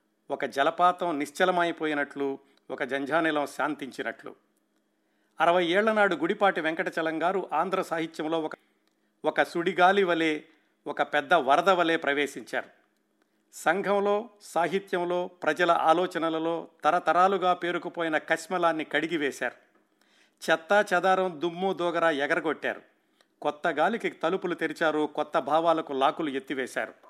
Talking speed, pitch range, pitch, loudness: 95 wpm, 150-180 Hz, 165 Hz, -27 LUFS